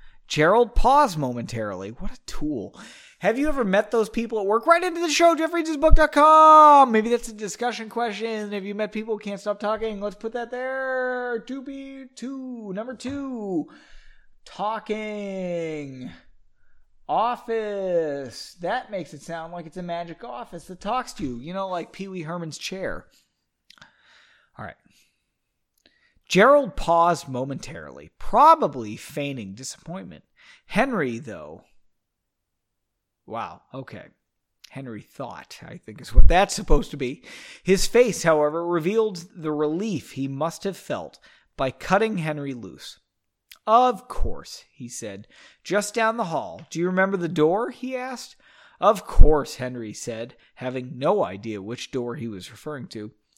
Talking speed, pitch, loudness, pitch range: 140 wpm, 205 Hz, -23 LUFS, 160-245 Hz